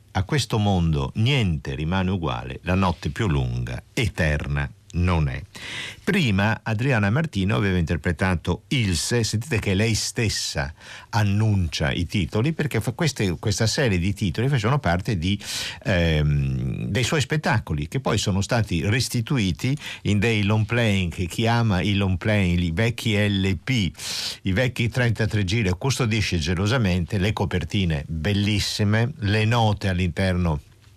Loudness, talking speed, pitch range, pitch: -23 LUFS, 135 wpm, 90-115 Hz, 105 Hz